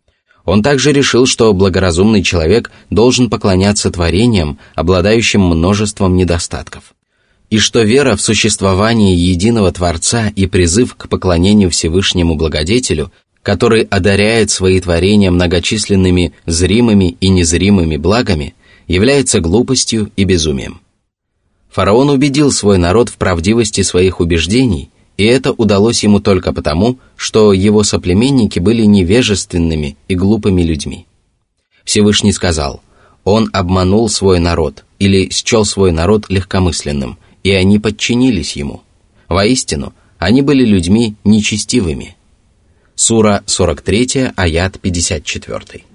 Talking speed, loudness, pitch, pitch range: 110 wpm, -11 LUFS, 100 Hz, 90-110 Hz